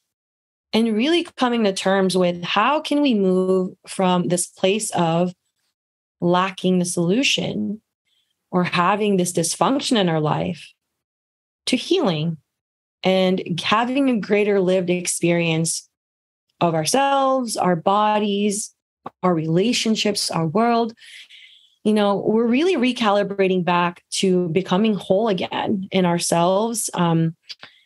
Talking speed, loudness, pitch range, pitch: 115 wpm, -20 LUFS, 175-215 Hz, 190 Hz